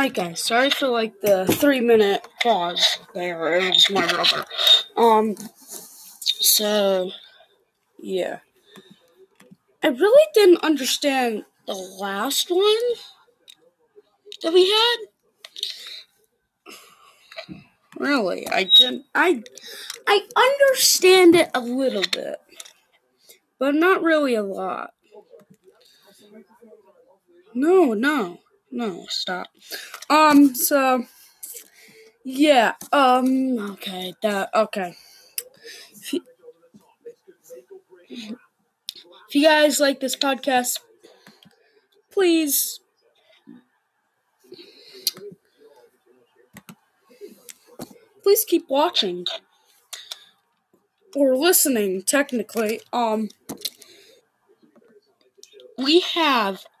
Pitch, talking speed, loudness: 295 Hz, 75 wpm, -19 LUFS